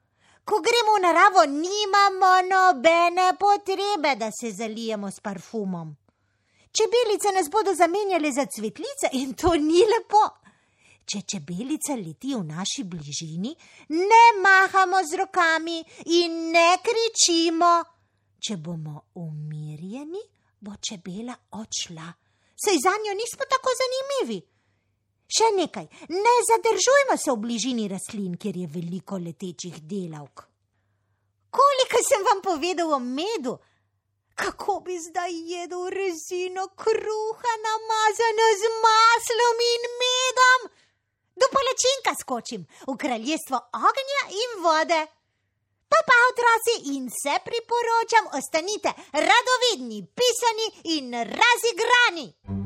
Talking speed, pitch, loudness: 110 wpm, 335 Hz, -22 LUFS